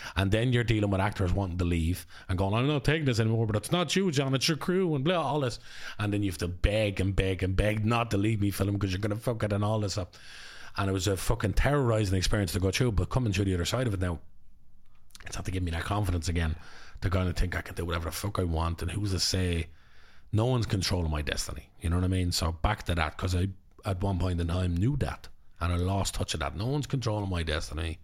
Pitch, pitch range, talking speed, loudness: 95 Hz, 90-110 Hz, 275 wpm, -29 LUFS